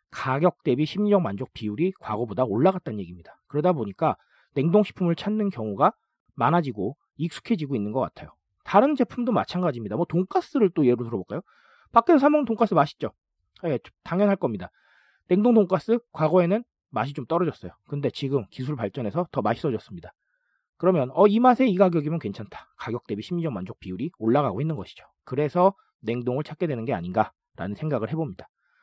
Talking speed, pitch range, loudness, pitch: 405 characters per minute, 125-200 Hz, -25 LUFS, 160 Hz